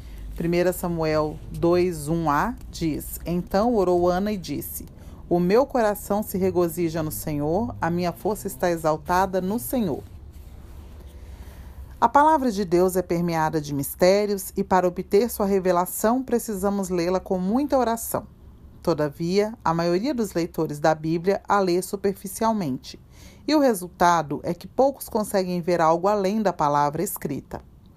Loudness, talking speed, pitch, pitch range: -23 LUFS, 135 wpm, 180 Hz, 160-205 Hz